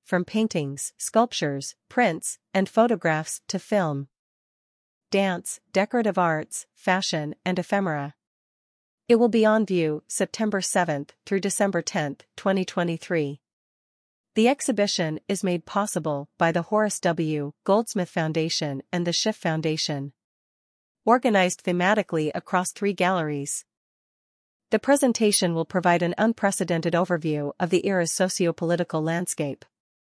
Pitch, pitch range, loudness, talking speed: 180 Hz, 155-200 Hz, -24 LUFS, 115 wpm